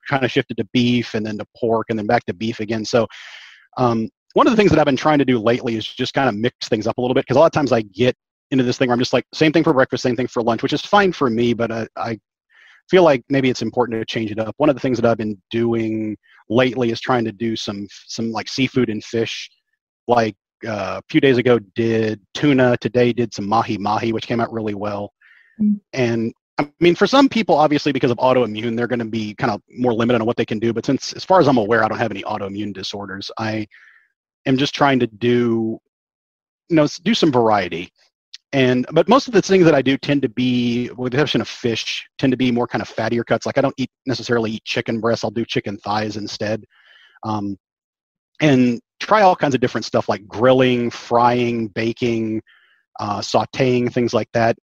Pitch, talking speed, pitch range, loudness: 120 Hz, 235 wpm, 110-130 Hz, -19 LUFS